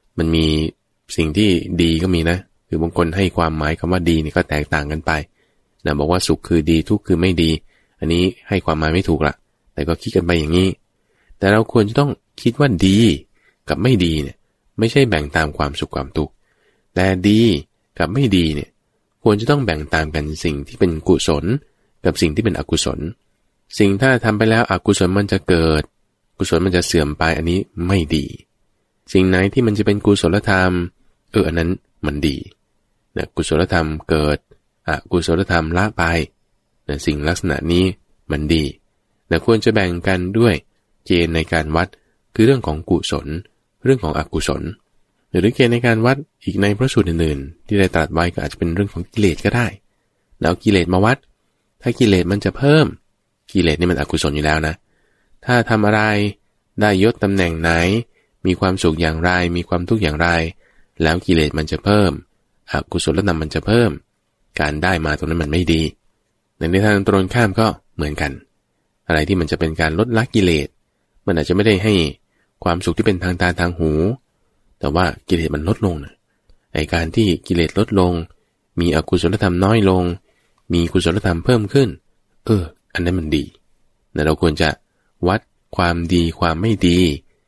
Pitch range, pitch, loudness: 80-105 Hz, 90 Hz, -18 LUFS